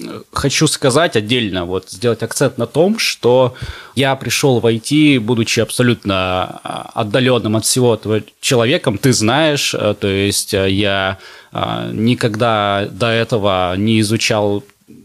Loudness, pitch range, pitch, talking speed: -15 LUFS, 105-125 Hz, 115 Hz, 120 wpm